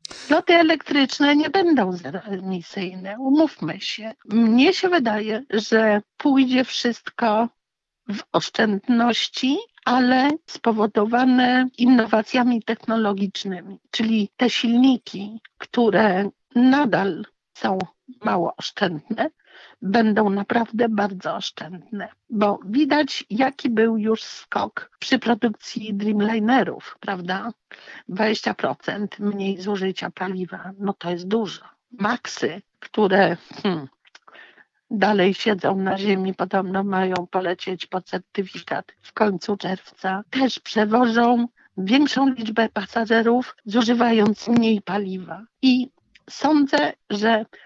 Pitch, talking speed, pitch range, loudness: 220 Hz, 95 wpm, 200-255 Hz, -21 LUFS